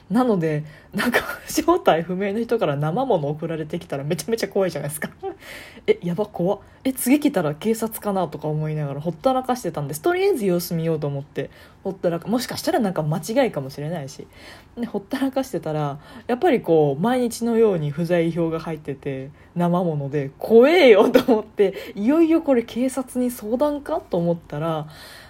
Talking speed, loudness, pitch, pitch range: 390 characters per minute, -22 LUFS, 190 Hz, 160-245 Hz